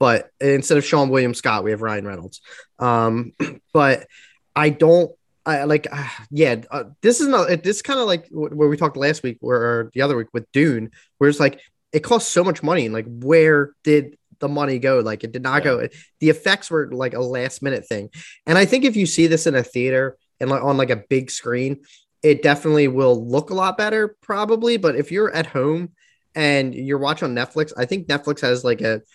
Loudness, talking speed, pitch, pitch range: -19 LUFS, 220 wpm, 145 Hz, 125-160 Hz